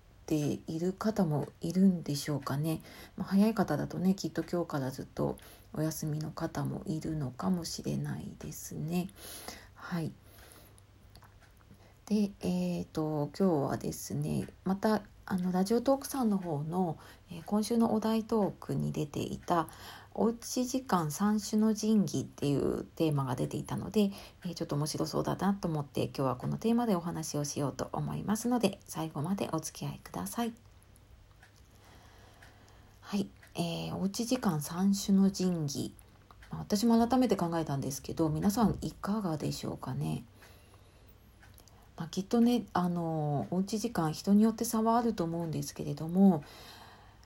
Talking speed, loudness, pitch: 305 characters per minute, -32 LUFS, 165 Hz